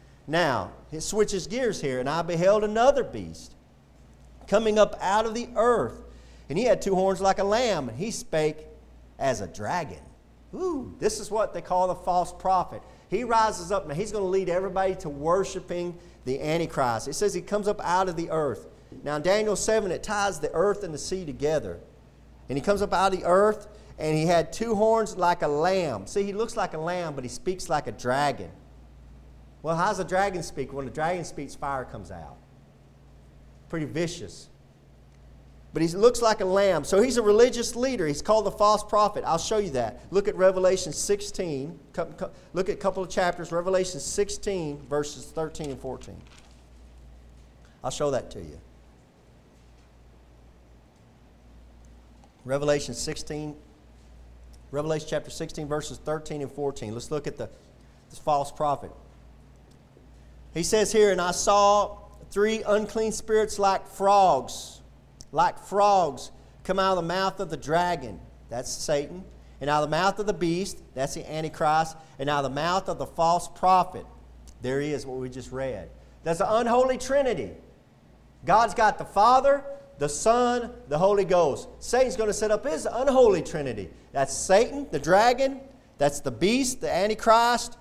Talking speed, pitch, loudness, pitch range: 175 wpm, 170 Hz, -26 LUFS, 135-205 Hz